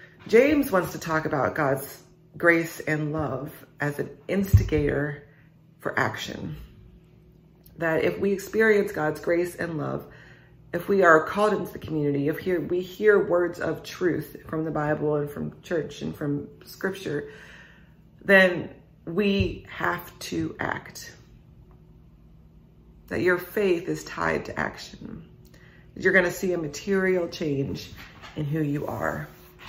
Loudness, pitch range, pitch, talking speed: -25 LUFS, 145-180 Hz, 160 Hz, 140 wpm